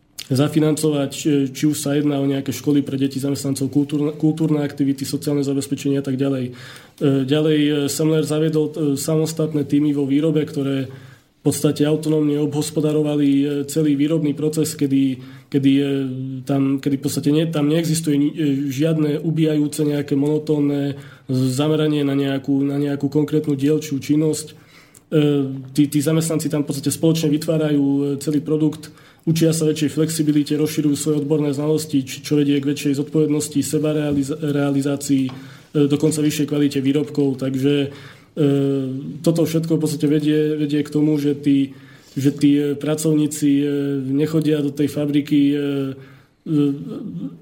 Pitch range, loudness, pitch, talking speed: 140-150 Hz, -19 LUFS, 145 Hz, 125 wpm